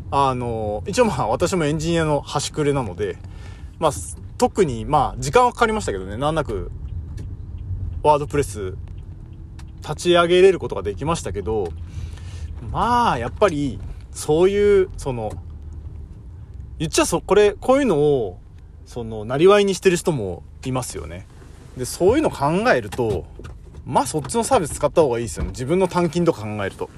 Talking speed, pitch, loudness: 335 characters per minute, 120 Hz, -20 LUFS